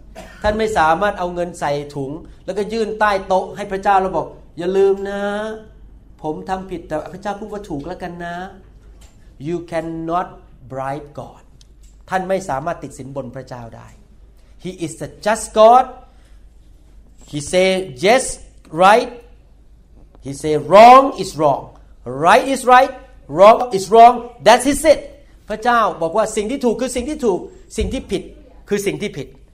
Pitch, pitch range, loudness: 185 Hz, 150-215 Hz, -16 LUFS